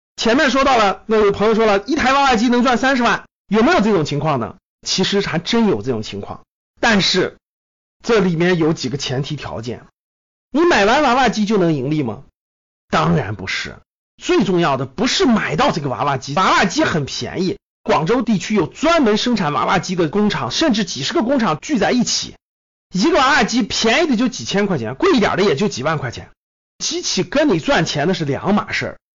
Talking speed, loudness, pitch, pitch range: 300 characters per minute, -17 LUFS, 200 Hz, 155-245 Hz